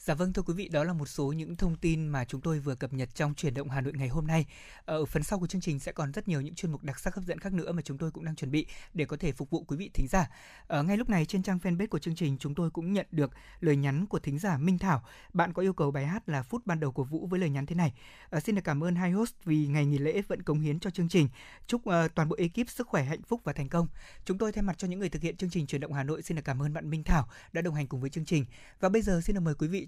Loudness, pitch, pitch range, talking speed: -32 LUFS, 160 Hz, 145-185 Hz, 330 wpm